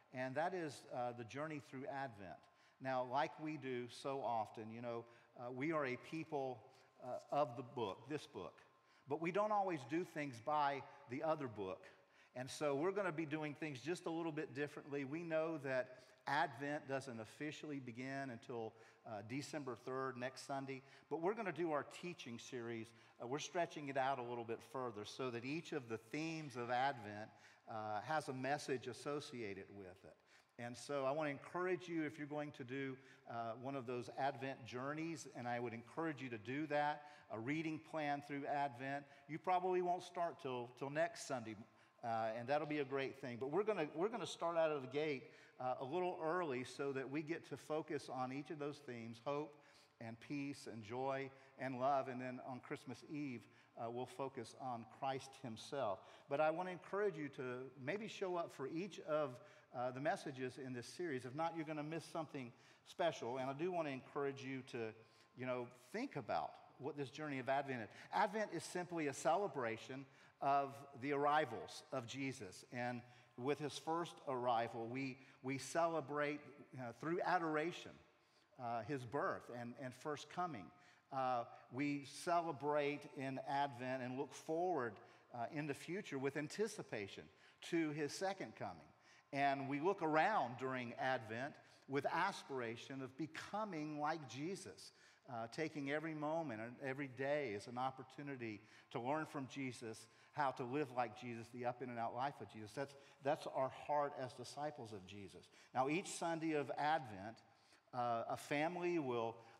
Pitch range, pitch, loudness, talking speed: 125-150 Hz, 135 Hz, -44 LUFS, 180 wpm